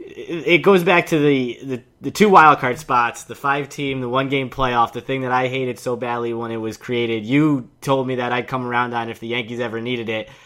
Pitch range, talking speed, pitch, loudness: 120-140 Hz, 255 wpm, 125 Hz, -19 LUFS